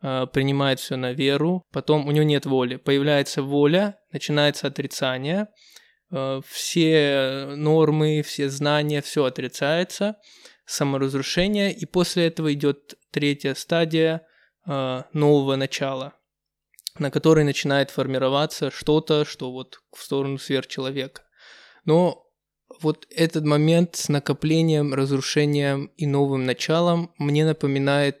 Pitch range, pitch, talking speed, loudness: 135-160 Hz, 145 Hz, 105 wpm, -22 LUFS